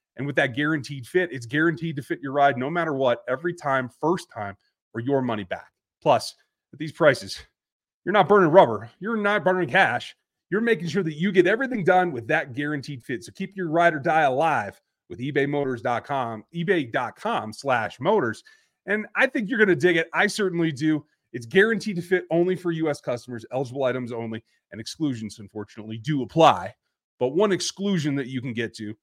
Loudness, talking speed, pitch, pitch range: -23 LUFS, 185 wpm, 155 Hz, 125-185 Hz